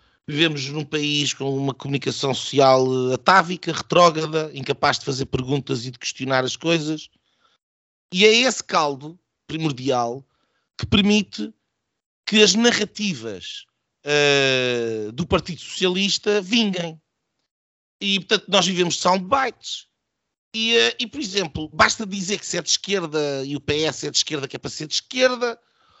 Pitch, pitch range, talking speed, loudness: 155 Hz, 135-200 Hz, 145 wpm, -20 LUFS